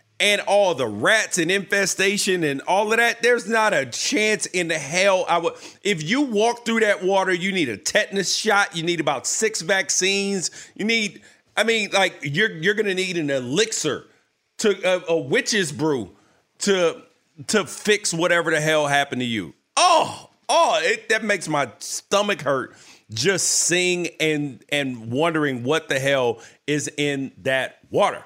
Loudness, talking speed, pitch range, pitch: -21 LUFS, 170 wpm, 150-205 Hz, 185 Hz